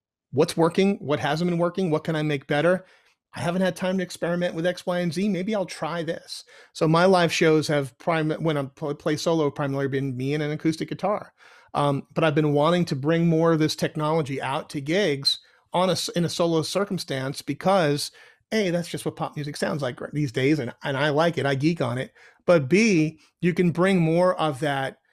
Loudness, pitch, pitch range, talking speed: -24 LUFS, 160 Hz, 145-175 Hz, 215 wpm